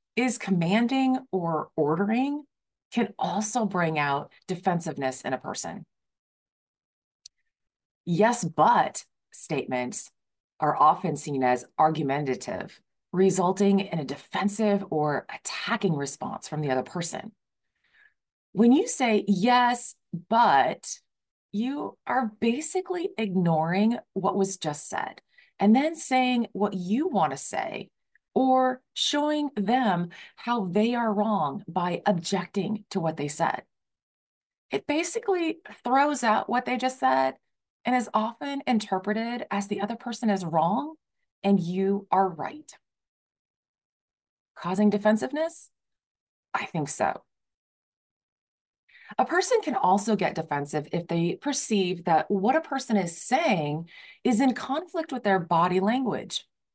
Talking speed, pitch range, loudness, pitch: 120 wpm, 170-245 Hz, -26 LUFS, 205 Hz